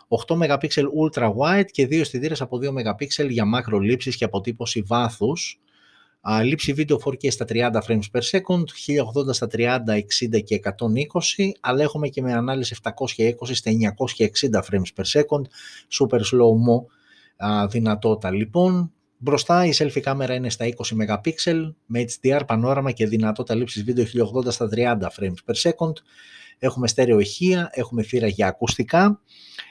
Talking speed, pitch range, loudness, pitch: 145 wpm, 115-145 Hz, -22 LUFS, 125 Hz